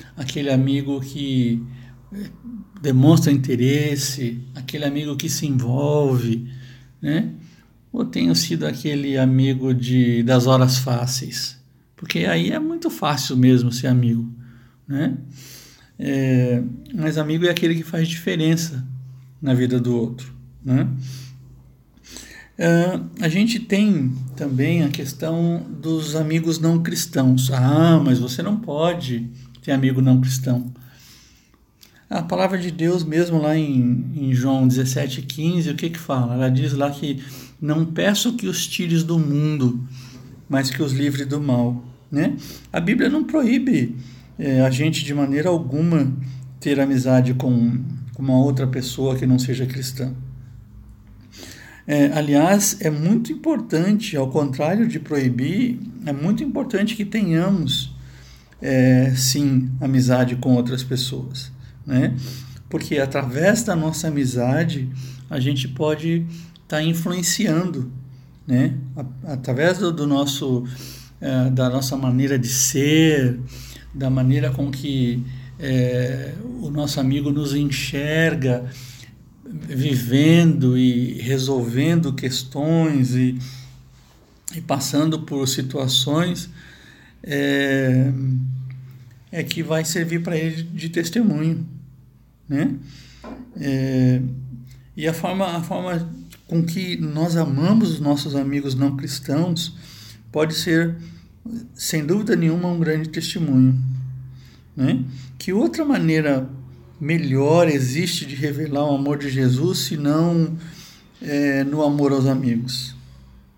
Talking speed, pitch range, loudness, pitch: 120 wpm, 130-160 Hz, -20 LUFS, 140 Hz